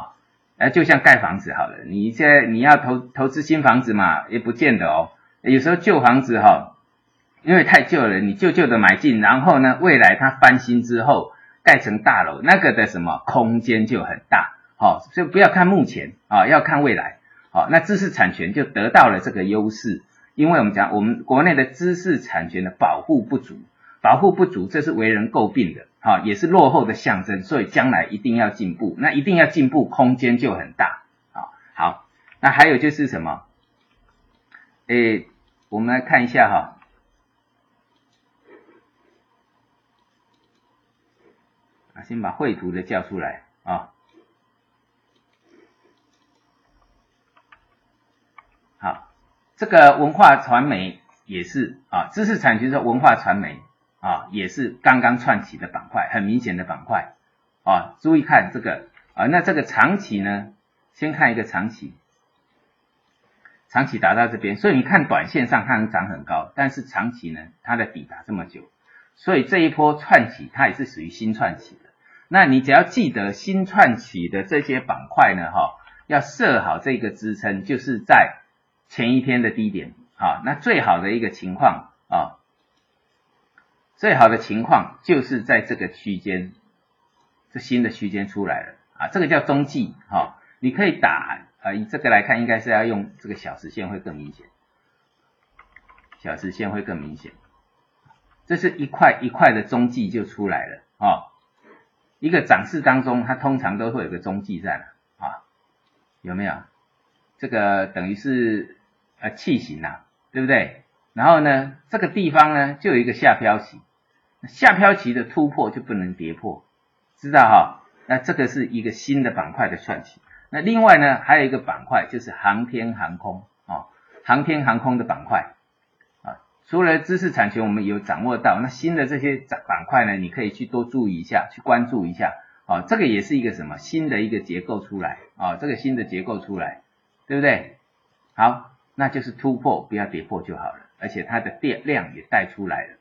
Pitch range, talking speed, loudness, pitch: 105-145 Hz, 250 characters per minute, -18 LUFS, 120 Hz